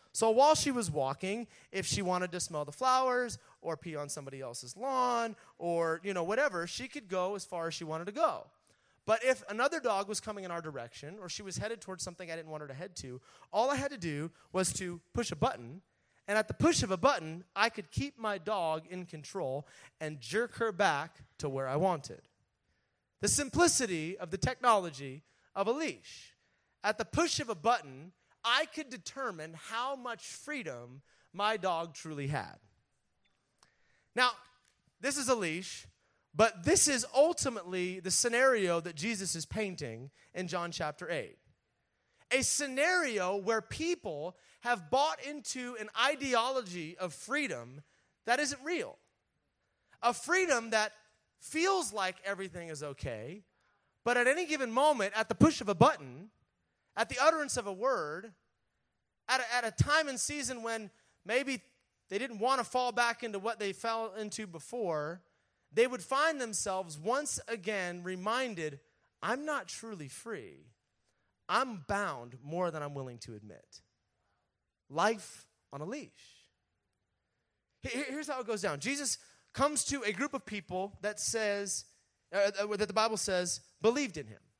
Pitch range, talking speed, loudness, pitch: 165-250 Hz, 165 wpm, -33 LUFS, 205 Hz